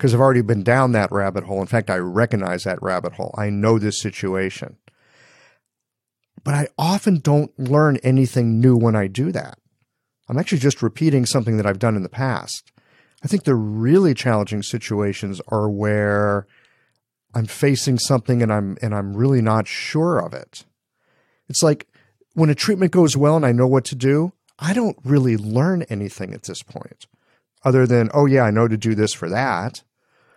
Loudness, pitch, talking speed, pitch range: -19 LUFS, 120 Hz, 185 wpm, 105-140 Hz